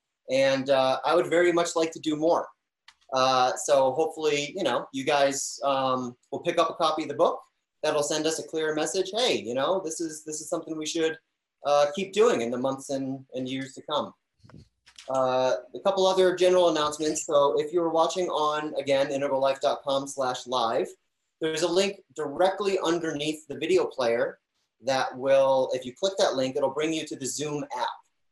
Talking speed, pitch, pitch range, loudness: 190 wpm, 155 Hz, 135-170 Hz, -26 LUFS